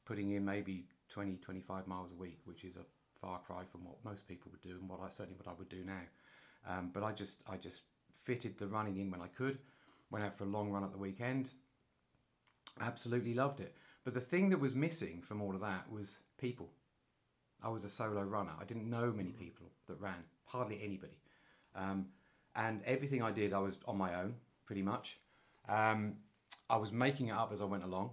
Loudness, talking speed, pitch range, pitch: -41 LUFS, 215 wpm, 95-120 Hz, 100 Hz